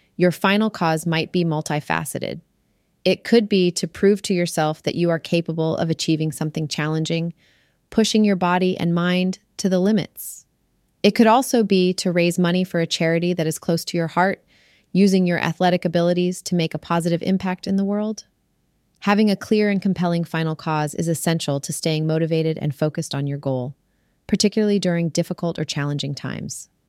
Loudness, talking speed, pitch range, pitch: -21 LUFS, 180 wpm, 160-190 Hz, 170 Hz